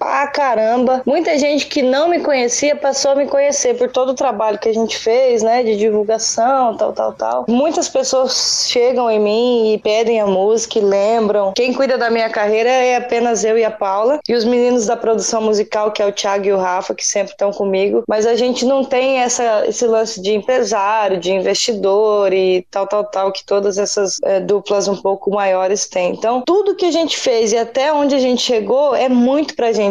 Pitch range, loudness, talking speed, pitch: 205-260 Hz, -15 LUFS, 215 wpm, 230 Hz